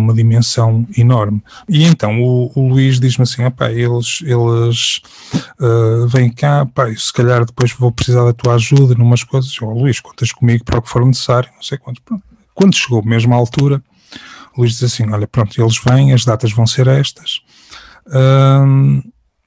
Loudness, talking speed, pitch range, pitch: -13 LUFS, 180 wpm, 115-135 Hz, 125 Hz